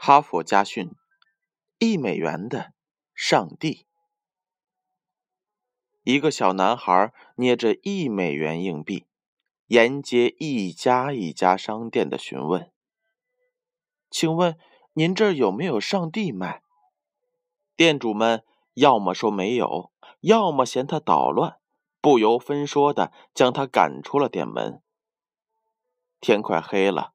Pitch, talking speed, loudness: 165 Hz, 165 characters per minute, -22 LUFS